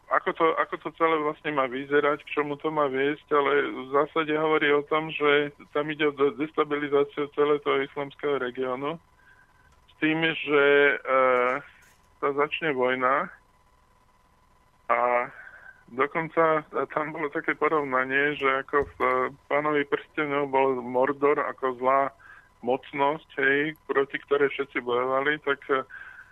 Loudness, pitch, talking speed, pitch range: -25 LUFS, 145 Hz, 130 wpm, 130-150 Hz